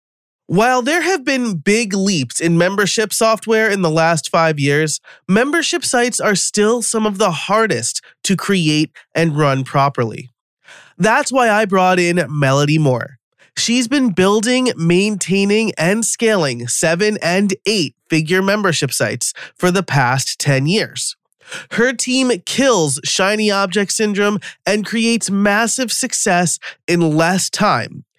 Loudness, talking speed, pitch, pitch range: -15 LUFS, 135 wpm, 195 Hz, 165-225 Hz